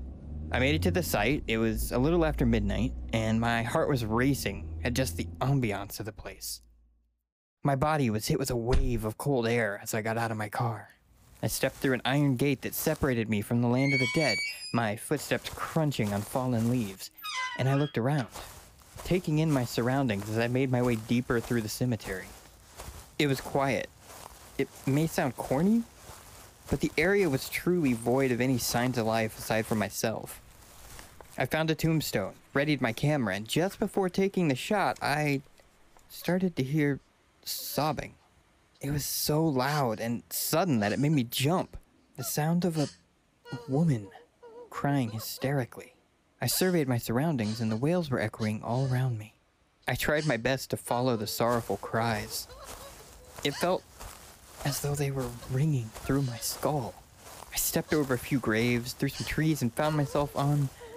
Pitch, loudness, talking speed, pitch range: 125 Hz, -29 LUFS, 175 wpm, 110-145 Hz